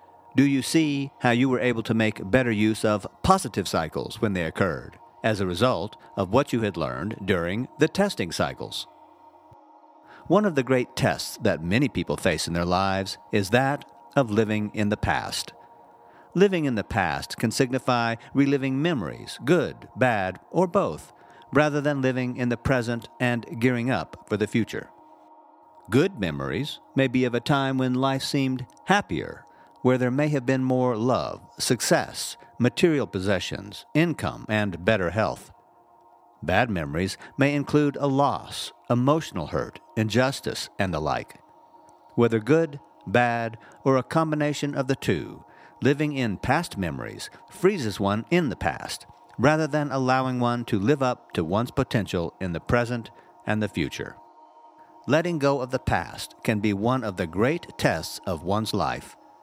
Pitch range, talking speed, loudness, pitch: 105-140 Hz, 160 wpm, -25 LUFS, 125 Hz